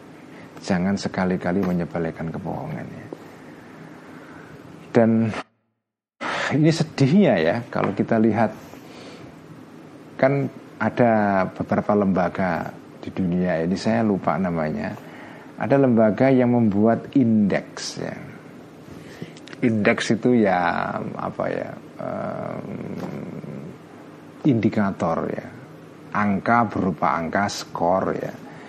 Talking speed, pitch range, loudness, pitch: 85 wpm, 100-125 Hz, -22 LUFS, 110 Hz